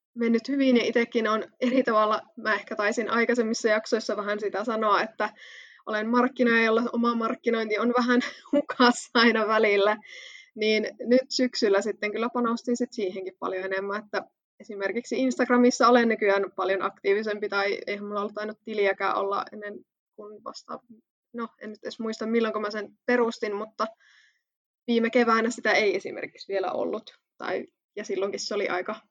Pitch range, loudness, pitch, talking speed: 210-240 Hz, -25 LUFS, 225 Hz, 160 wpm